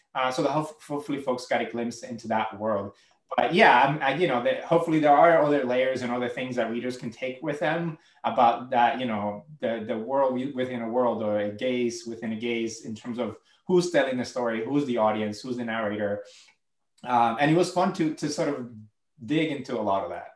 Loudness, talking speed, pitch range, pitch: -26 LUFS, 220 wpm, 115-145 Hz, 125 Hz